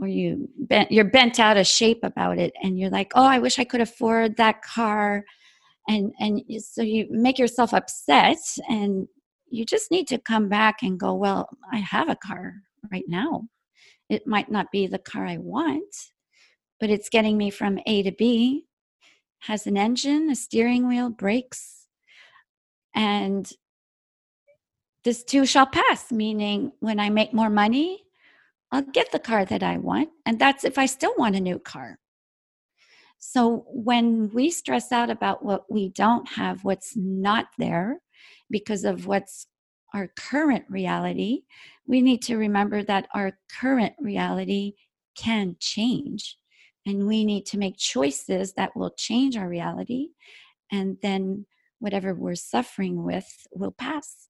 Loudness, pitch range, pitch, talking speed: -23 LUFS, 200-255 Hz, 220 Hz, 155 wpm